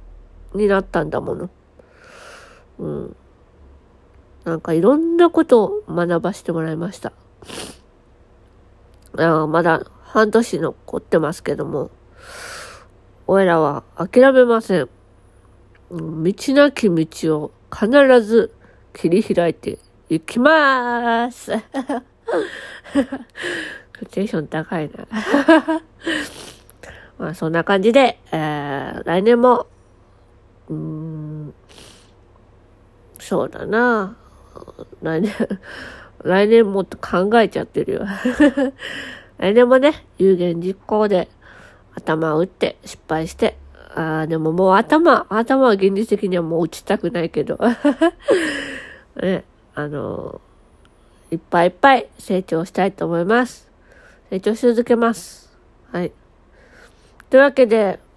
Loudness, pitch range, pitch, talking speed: -18 LUFS, 160-245 Hz, 190 Hz, 195 characters per minute